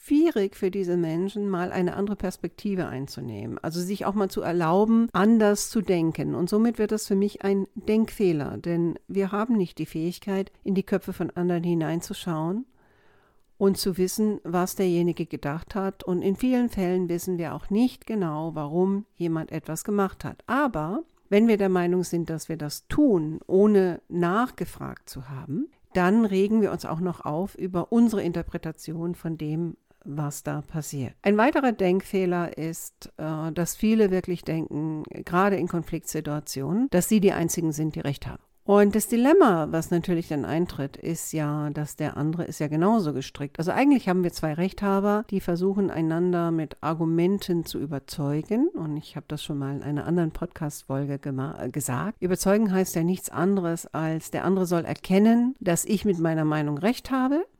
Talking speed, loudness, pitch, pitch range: 170 wpm, -25 LUFS, 175 Hz, 160-200 Hz